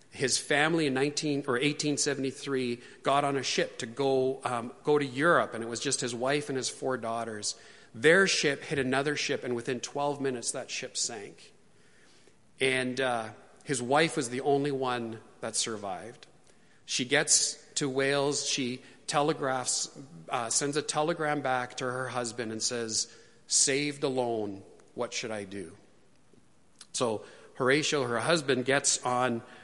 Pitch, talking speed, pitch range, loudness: 135 Hz, 160 wpm, 125-145 Hz, -29 LUFS